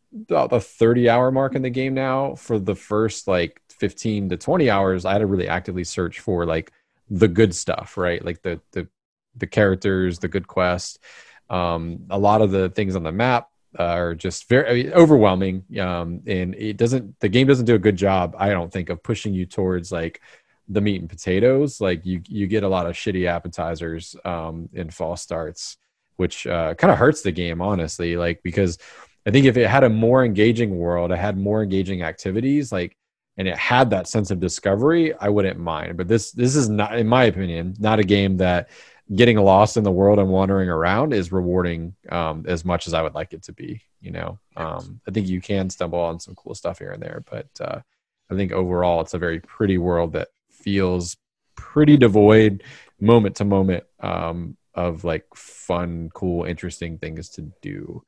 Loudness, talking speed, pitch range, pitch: -20 LUFS, 200 wpm, 90-110 Hz, 95 Hz